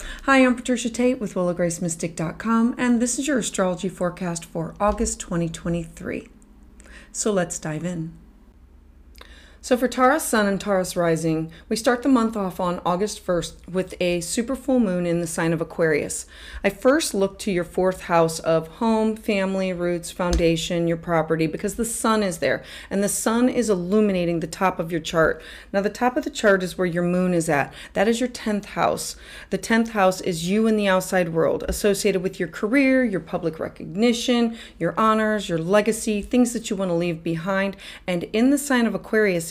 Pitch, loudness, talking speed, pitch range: 195 Hz, -22 LUFS, 185 wpm, 175-225 Hz